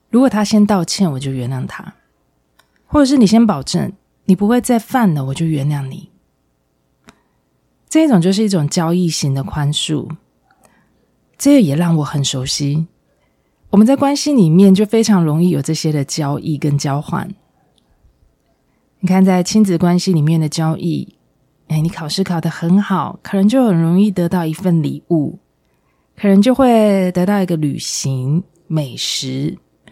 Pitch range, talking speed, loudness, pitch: 155-200 Hz, 230 characters per minute, -15 LUFS, 175 Hz